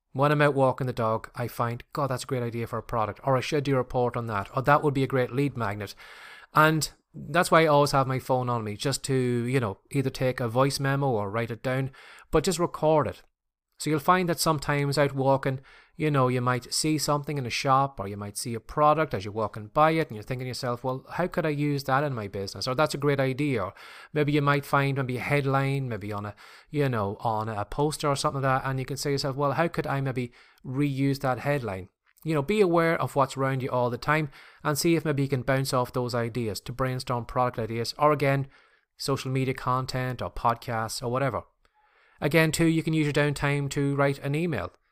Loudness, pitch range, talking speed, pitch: -27 LUFS, 125-145 Hz, 245 wpm, 135 Hz